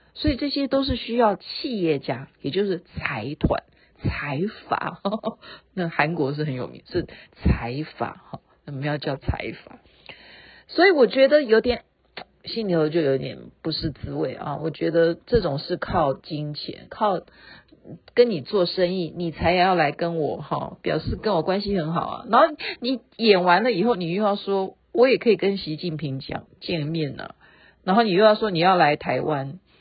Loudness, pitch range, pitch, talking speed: -23 LUFS, 155-220 Hz, 175 Hz, 240 characters per minute